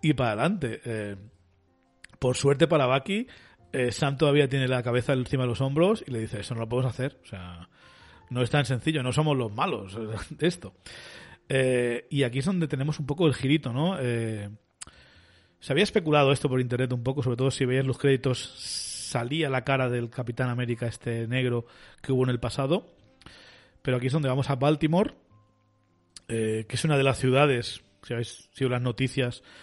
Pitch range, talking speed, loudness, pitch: 115-140 Hz, 195 wpm, -27 LUFS, 125 Hz